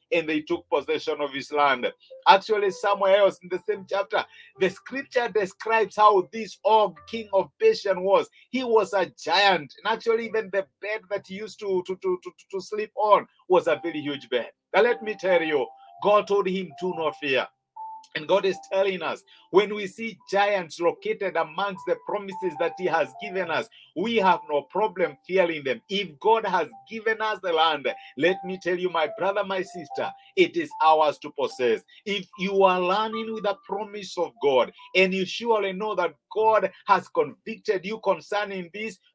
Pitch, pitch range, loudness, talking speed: 200 Hz, 185-225 Hz, -25 LUFS, 190 wpm